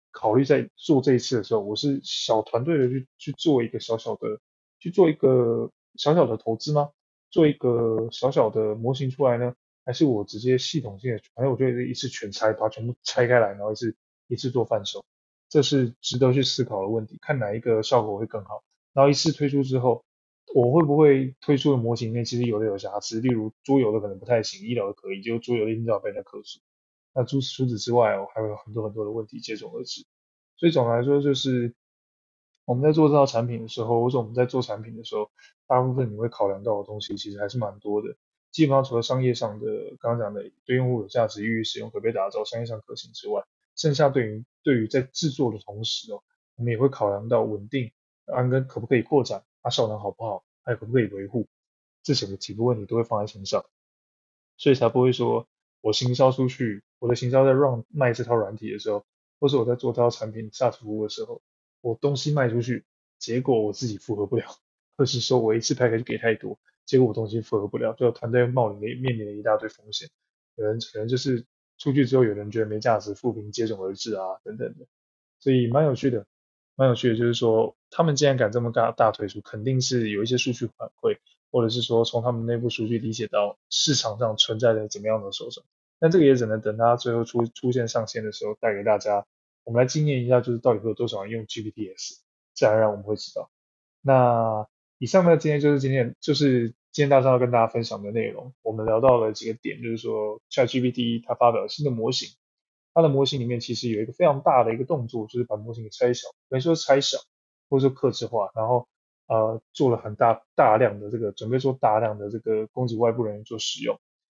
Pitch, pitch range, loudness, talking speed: 120 Hz, 110-130 Hz, -24 LUFS, 345 characters per minute